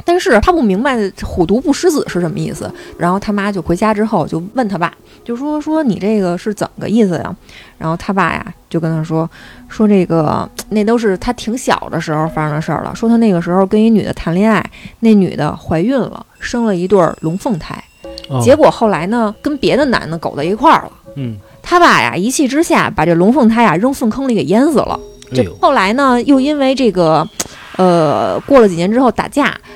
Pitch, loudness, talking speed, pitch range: 210 Hz, -13 LUFS, 305 characters per minute, 175-245 Hz